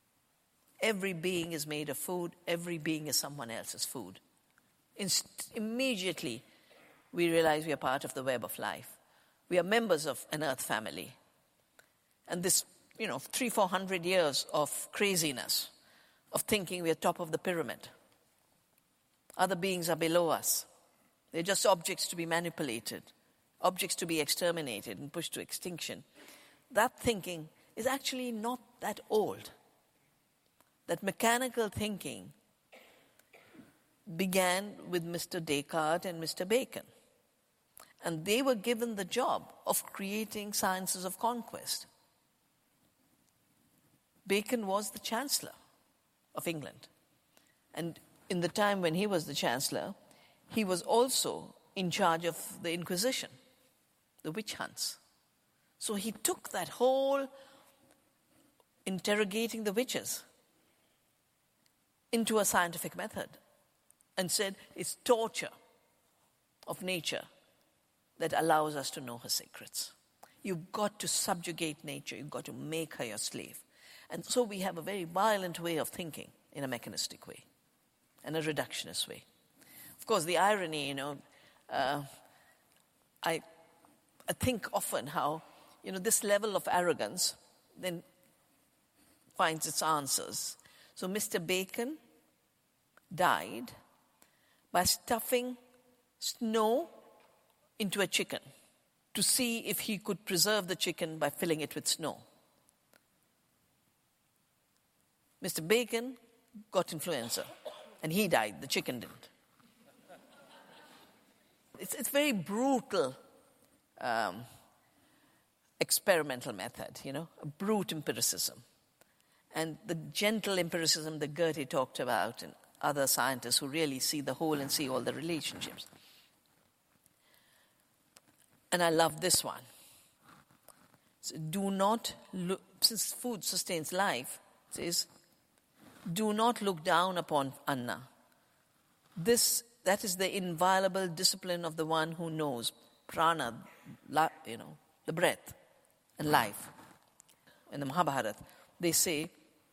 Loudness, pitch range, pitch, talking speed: -33 LUFS, 160-215 Hz, 185 Hz, 125 wpm